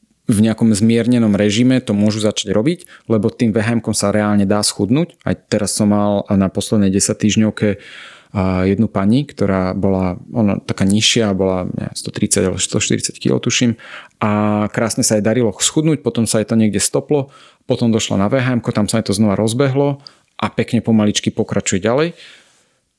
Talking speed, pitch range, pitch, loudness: 165 wpm, 100-120 Hz, 110 Hz, -16 LUFS